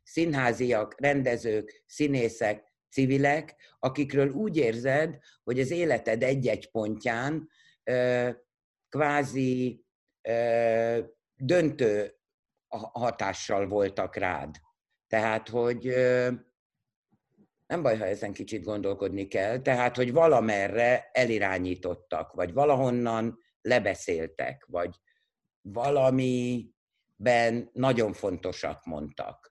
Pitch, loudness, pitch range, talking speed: 125 Hz, -28 LUFS, 115-140 Hz, 85 wpm